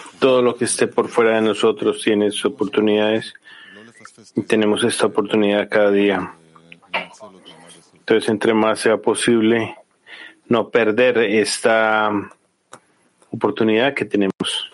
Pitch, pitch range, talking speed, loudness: 105 Hz, 100-110 Hz, 115 wpm, -18 LUFS